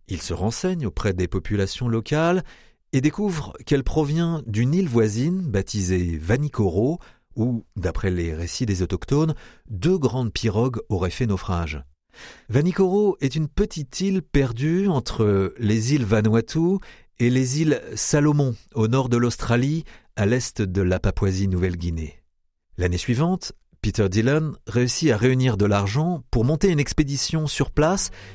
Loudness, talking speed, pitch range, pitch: -23 LUFS, 140 wpm, 100-150 Hz, 120 Hz